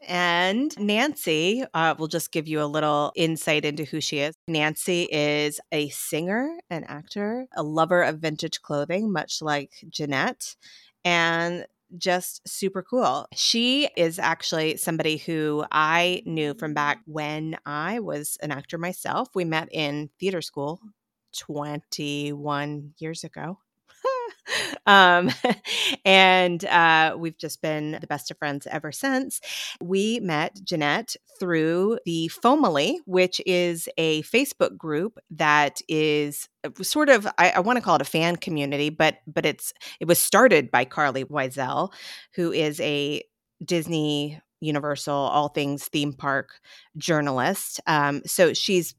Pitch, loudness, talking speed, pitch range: 160 Hz, -23 LUFS, 135 wpm, 150-185 Hz